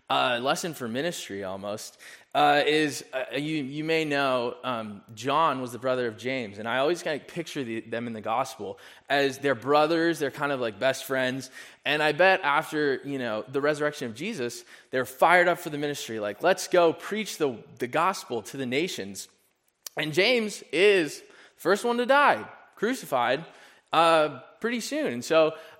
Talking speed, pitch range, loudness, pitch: 185 wpm, 125-160 Hz, -26 LUFS, 145 Hz